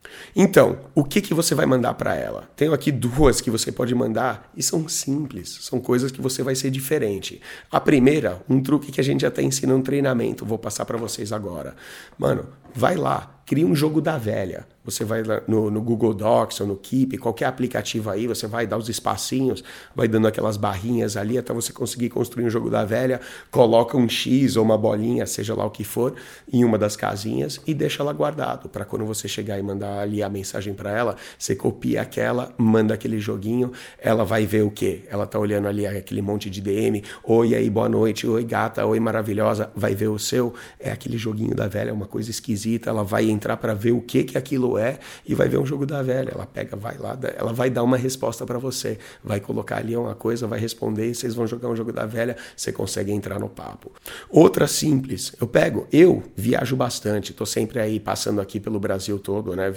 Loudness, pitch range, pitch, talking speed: -23 LUFS, 105-125 Hz, 115 Hz, 220 wpm